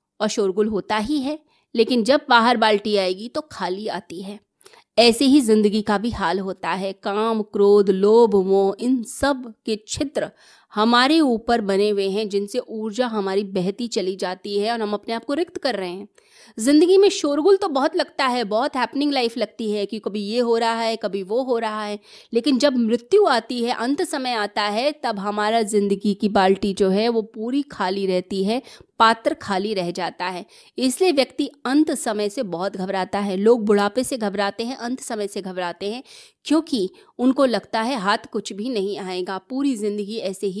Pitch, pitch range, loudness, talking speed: 220 Hz, 205-255 Hz, -21 LUFS, 190 wpm